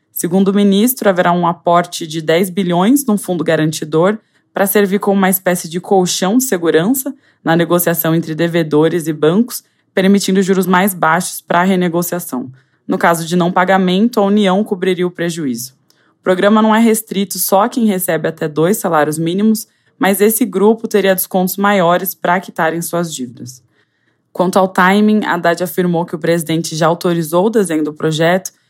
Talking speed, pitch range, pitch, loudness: 170 wpm, 165-200 Hz, 180 Hz, -14 LUFS